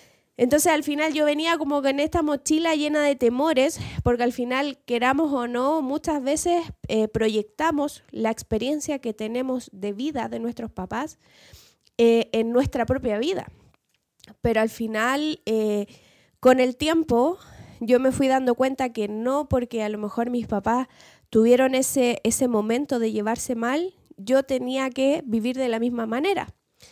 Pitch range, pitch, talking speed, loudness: 230-290 Hz, 255 Hz, 160 wpm, -23 LUFS